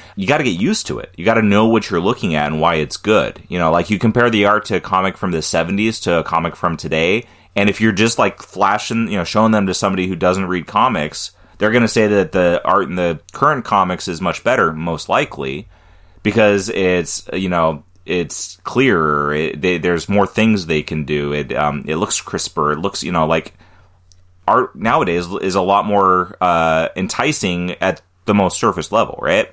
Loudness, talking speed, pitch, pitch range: -16 LUFS, 215 wpm, 90 Hz, 85-105 Hz